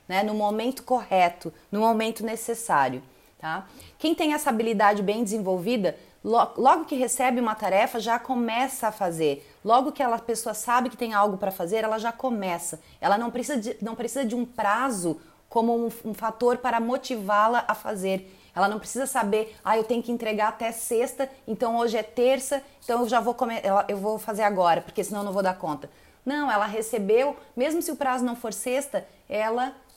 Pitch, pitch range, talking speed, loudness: 230 Hz, 210-250 Hz, 195 wpm, -26 LUFS